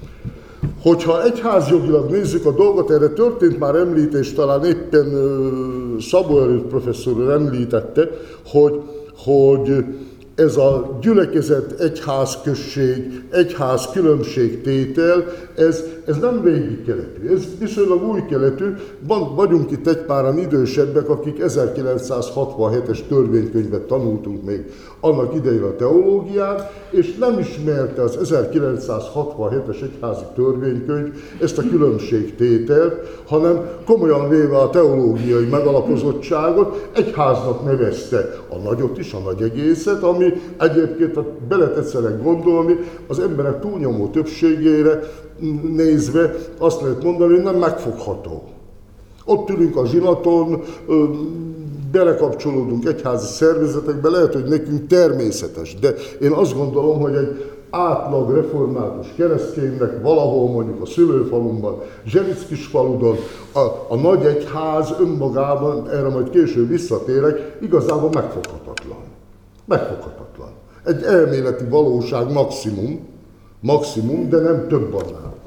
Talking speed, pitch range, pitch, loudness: 105 wpm, 130-170 Hz, 150 Hz, -17 LUFS